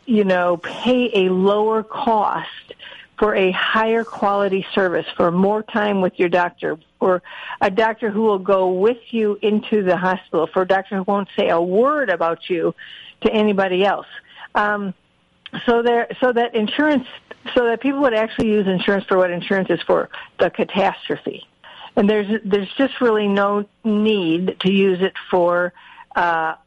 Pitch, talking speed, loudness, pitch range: 205 Hz, 165 wpm, -19 LUFS, 185-220 Hz